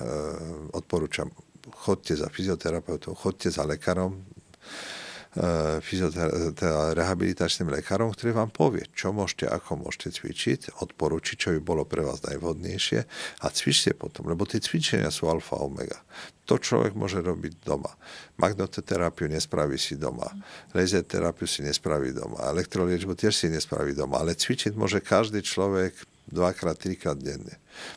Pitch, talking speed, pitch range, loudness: 90 Hz, 135 wpm, 80-95 Hz, -28 LUFS